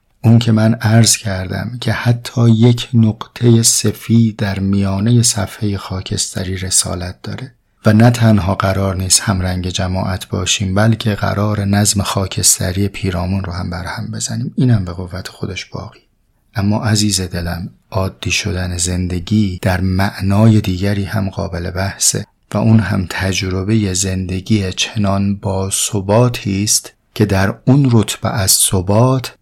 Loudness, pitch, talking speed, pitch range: -15 LUFS, 100 Hz, 135 wpm, 95-110 Hz